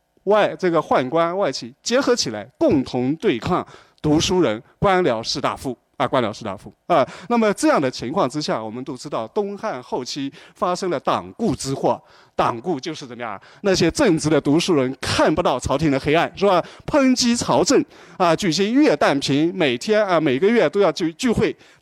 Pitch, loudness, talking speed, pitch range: 170 Hz, -20 LUFS, 290 characters per minute, 140-210 Hz